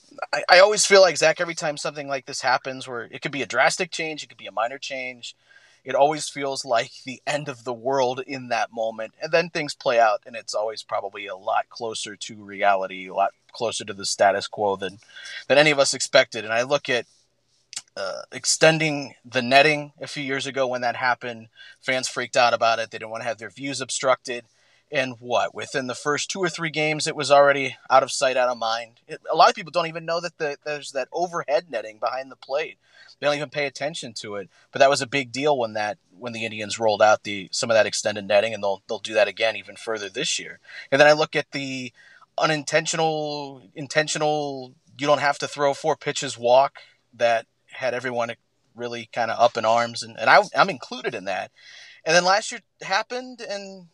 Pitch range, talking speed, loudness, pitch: 120-150 Hz, 225 wpm, -23 LUFS, 135 Hz